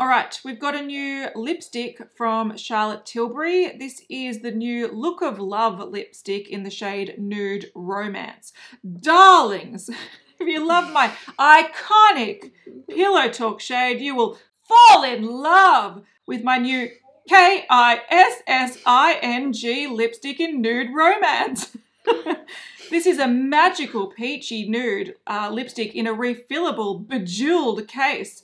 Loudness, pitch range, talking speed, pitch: -19 LUFS, 225-325 Hz, 135 wpm, 250 Hz